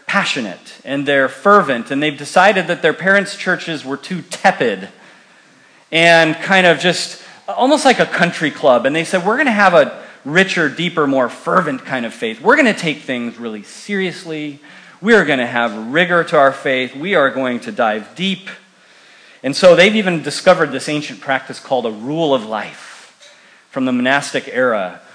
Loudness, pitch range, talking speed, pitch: -15 LUFS, 135-185 Hz, 180 wpm, 160 Hz